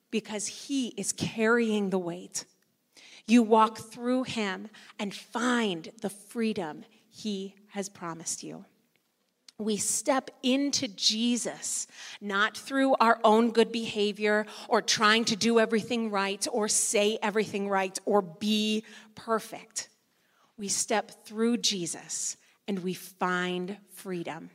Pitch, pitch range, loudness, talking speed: 215 Hz, 200-230 Hz, -28 LUFS, 120 wpm